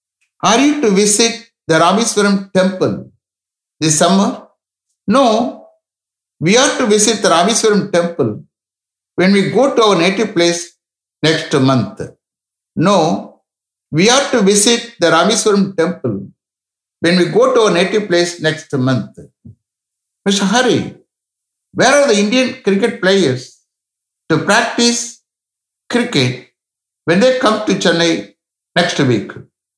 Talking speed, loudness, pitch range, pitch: 125 wpm, -13 LUFS, 150-225 Hz, 185 Hz